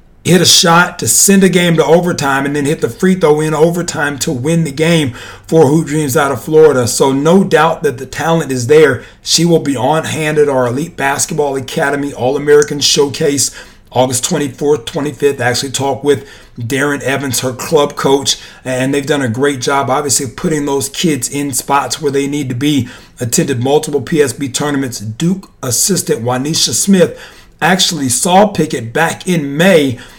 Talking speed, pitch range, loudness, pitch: 180 wpm, 135-160 Hz, -12 LUFS, 145 Hz